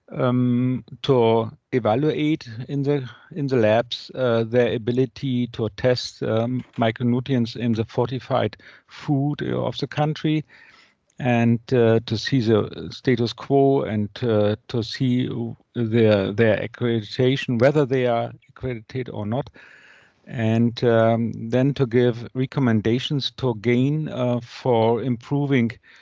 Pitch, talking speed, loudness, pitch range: 125 Hz, 120 wpm, -22 LUFS, 115-130 Hz